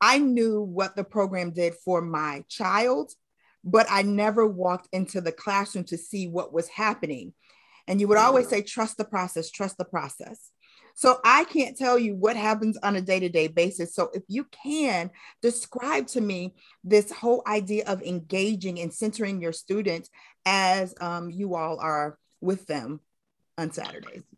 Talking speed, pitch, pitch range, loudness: 170 wpm, 195 Hz, 175-215 Hz, -26 LUFS